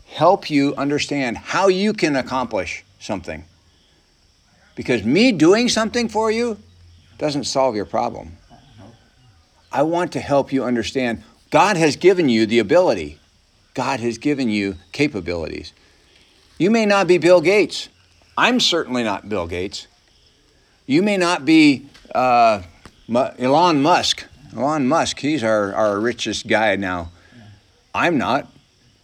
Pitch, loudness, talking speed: 120 Hz, -18 LUFS, 130 wpm